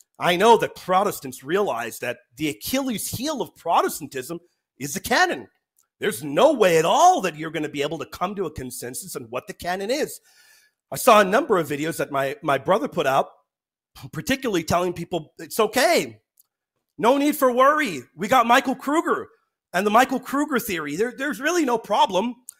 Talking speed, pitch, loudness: 185 wpm, 210 Hz, -22 LUFS